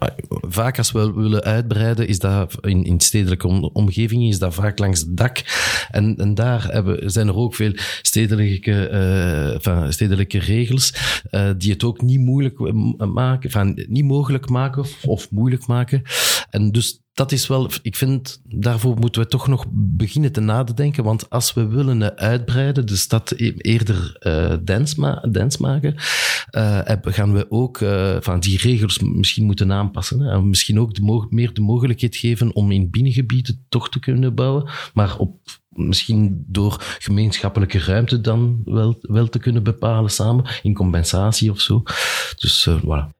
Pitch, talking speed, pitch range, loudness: 110 Hz, 165 wpm, 100-125 Hz, -18 LUFS